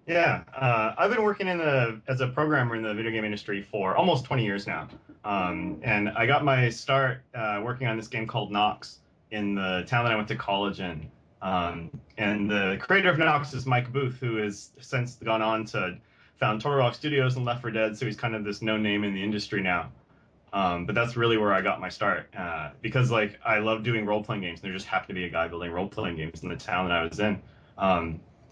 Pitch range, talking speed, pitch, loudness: 100-130 Hz, 240 wpm, 110 Hz, -27 LUFS